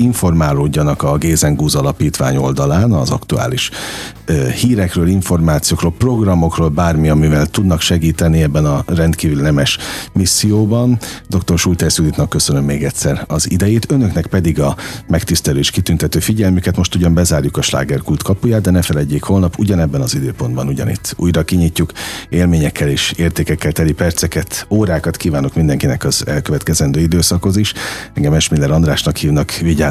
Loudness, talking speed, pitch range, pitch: -14 LUFS, 135 wpm, 75-90 Hz, 80 Hz